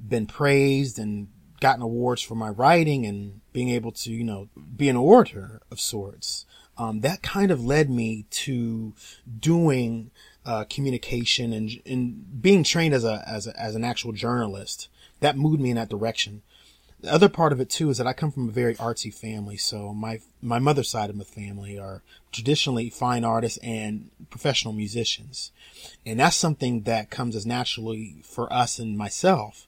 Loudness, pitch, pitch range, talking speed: -24 LUFS, 115 Hz, 110-135 Hz, 180 wpm